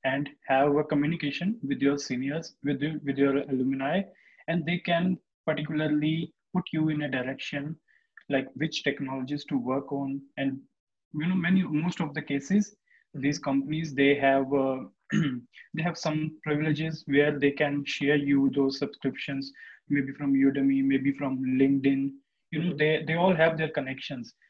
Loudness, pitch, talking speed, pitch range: -28 LUFS, 145 Hz, 160 wpm, 135-160 Hz